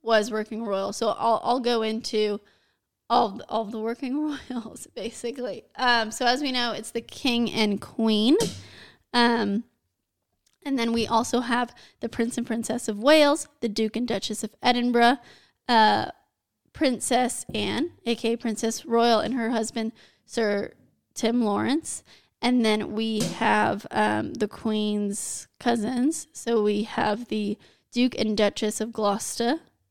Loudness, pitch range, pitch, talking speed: -25 LUFS, 215-245 Hz, 230 Hz, 150 wpm